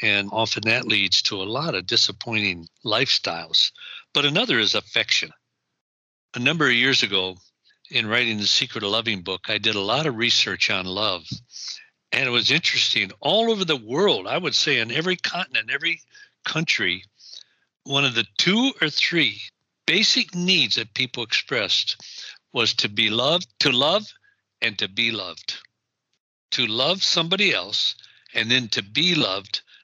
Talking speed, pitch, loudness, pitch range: 160 wpm, 120 Hz, -21 LUFS, 105-155 Hz